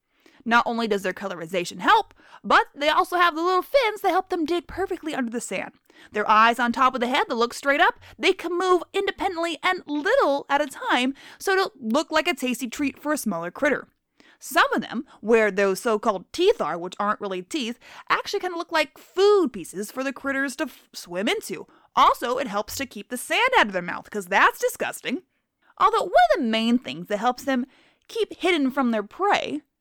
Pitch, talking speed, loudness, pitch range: 280 Hz, 215 wpm, -23 LUFS, 230-350 Hz